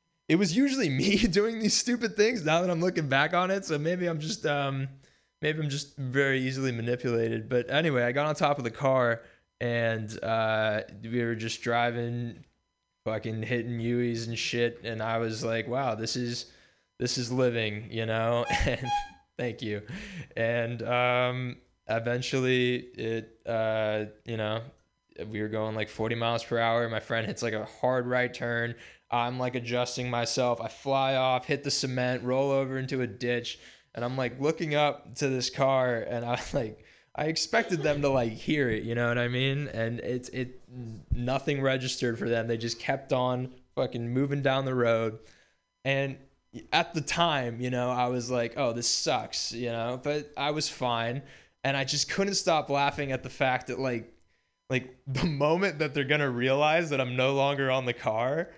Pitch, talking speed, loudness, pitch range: 125 Hz, 185 wpm, -29 LUFS, 115-140 Hz